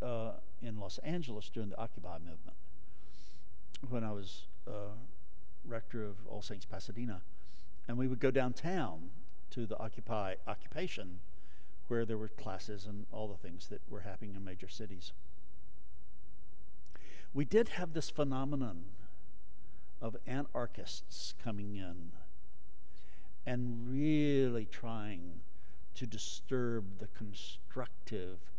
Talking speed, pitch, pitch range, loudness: 120 wpm, 100 Hz, 90-115 Hz, -41 LUFS